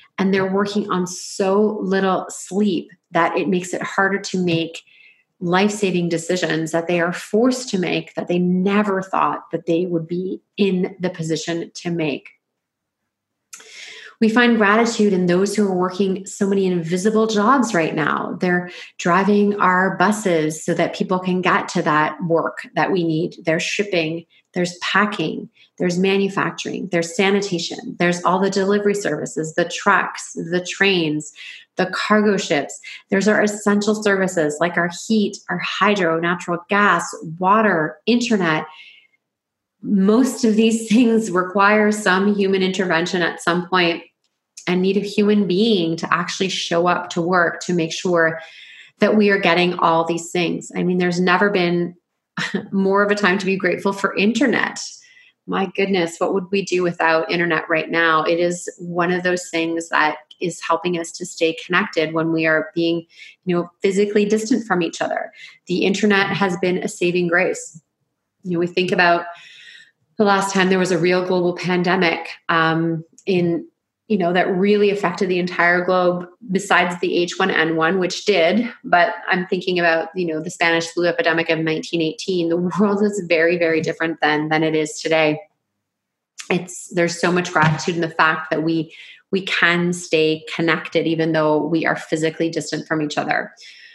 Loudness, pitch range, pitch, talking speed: -19 LUFS, 165-200 Hz, 180 Hz, 165 wpm